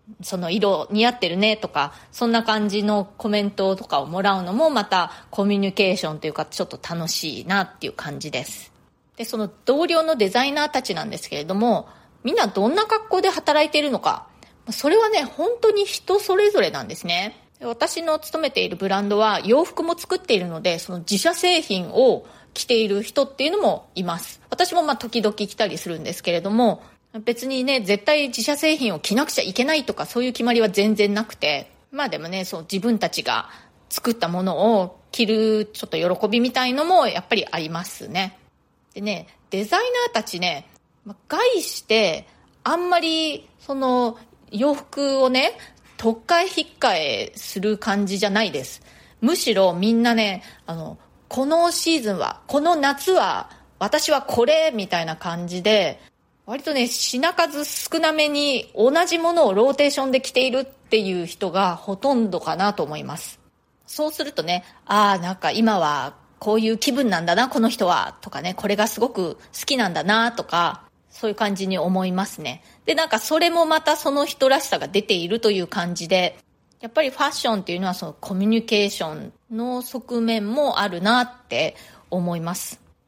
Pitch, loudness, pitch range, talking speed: 225 Hz, -21 LUFS, 195-285 Hz, 350 characters per minute